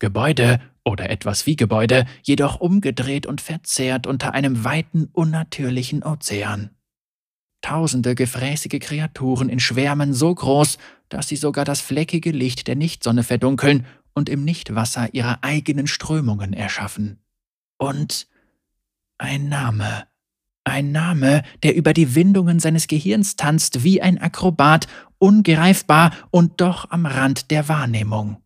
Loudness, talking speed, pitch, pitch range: -19 LUFS, 125 wpm, 140 Hz, 125-160 Hz